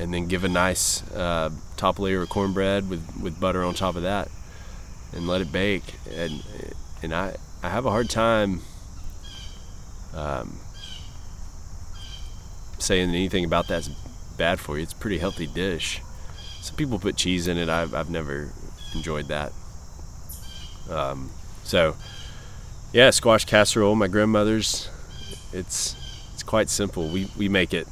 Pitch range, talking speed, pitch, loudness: 80-95 Hz, 145 wpm, 90 Hz, -24 LUFS